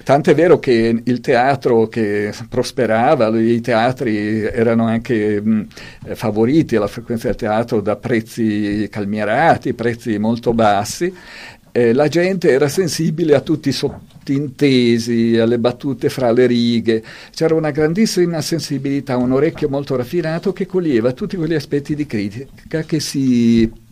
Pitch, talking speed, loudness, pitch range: 120 Hz, 135 wpm, -16 LUFS, 115-150 Hz